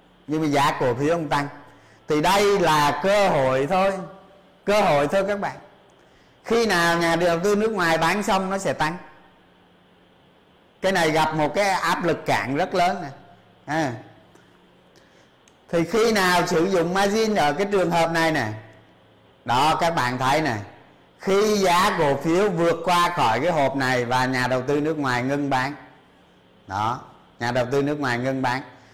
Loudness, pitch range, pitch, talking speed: -21 LUFS, 135-185 Hz, 155 Hz, 175 wpm